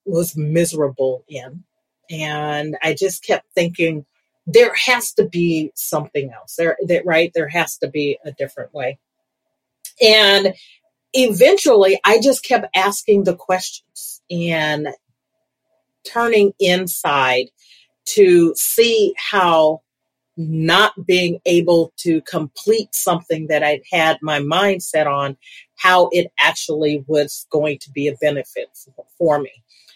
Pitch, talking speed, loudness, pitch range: 170 Hz, 125 wpm, -16 LUFS, 150-200 Hz